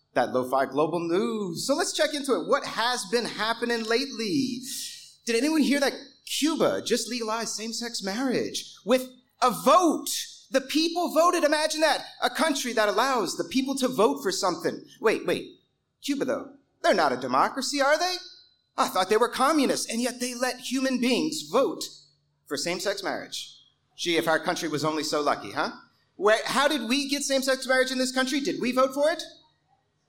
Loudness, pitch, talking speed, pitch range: -26 LUFS, 255 Hz, 180 wpm, 225-285 Hz